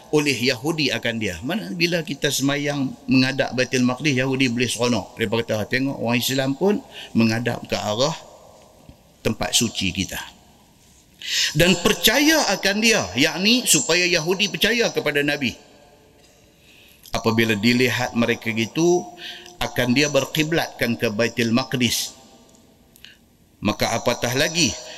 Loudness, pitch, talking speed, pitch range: -20 LUFS, 130 Hz, 120 wpm, 115-165 Hz